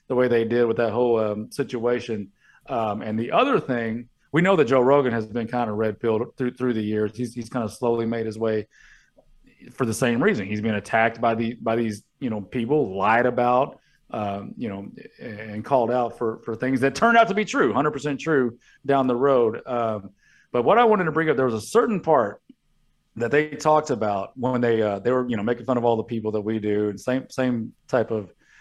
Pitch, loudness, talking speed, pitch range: 120 Hz, -23 LUFS, 235 wpm, 110-130 Hz